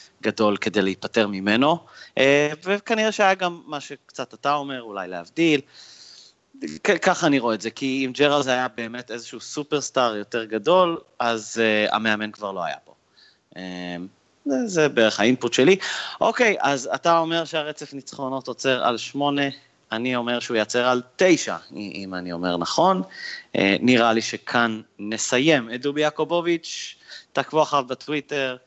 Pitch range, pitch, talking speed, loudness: 110-150 Hz, 125 Hz, 145 wpm, -22 LUFS